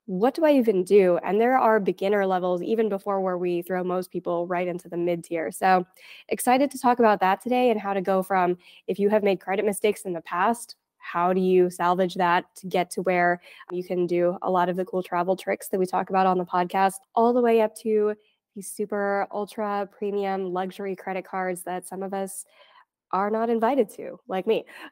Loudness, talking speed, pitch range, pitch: -24 LUFS, 220 wpm, 180-210 Hz, 190 Hz